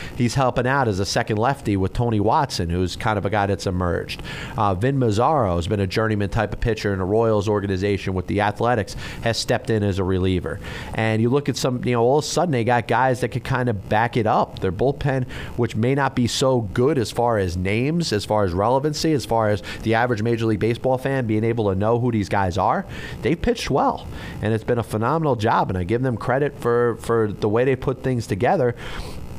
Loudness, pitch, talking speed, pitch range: -21 LUFS, 115 Hz, 235 wpm, 105-125 Hz